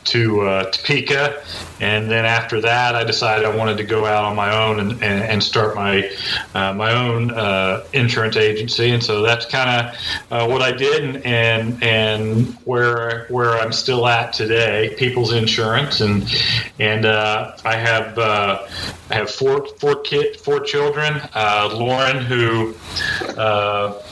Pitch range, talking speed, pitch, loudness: 105-120 Hz, 160 wpm, 115 Hz, -17 LUFS